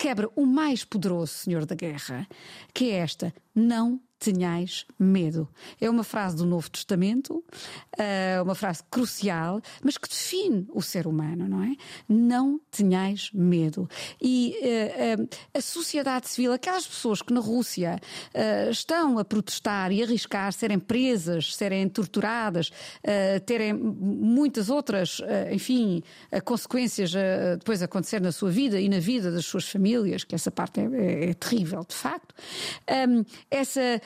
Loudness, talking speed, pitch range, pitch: -27 LUFS, 135 wpm, 185-245 Hz, 205 Hz